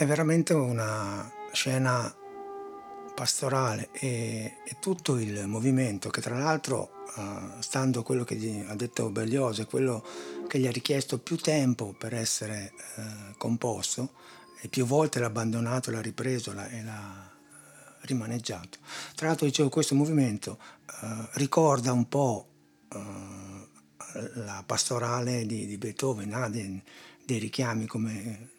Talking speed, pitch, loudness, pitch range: 135 wpm, 120 Hz, -30 LUFS, 110-135 Hz